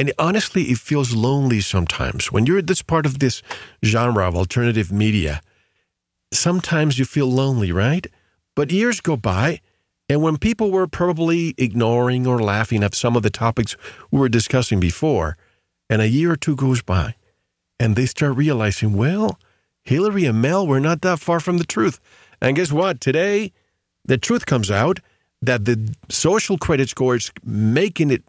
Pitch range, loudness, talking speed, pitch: 110-165 Hz, -19 LUFS, 170 wpm, 130 Hz